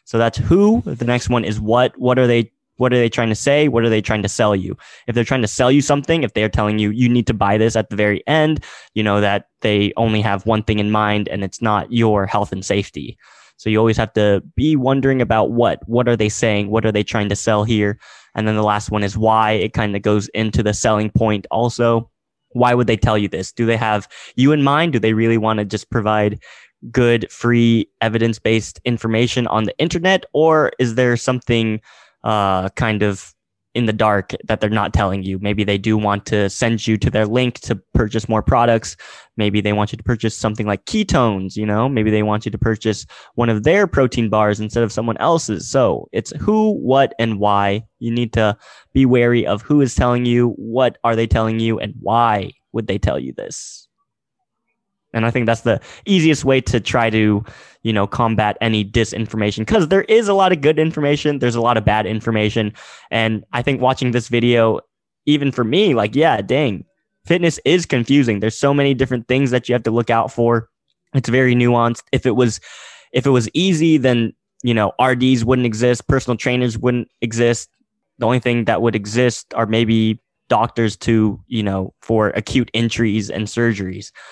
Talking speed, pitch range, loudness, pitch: 215 wpm, 105-125 Hz, -17 LUFS, 115 Hz